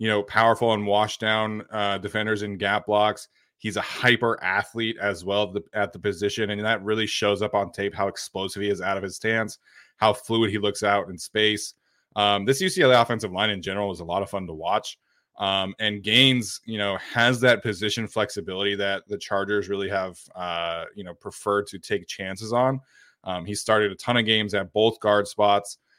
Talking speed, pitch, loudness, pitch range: 210 wpm, 105 Hz, -24 LUFS, 100-110 Hz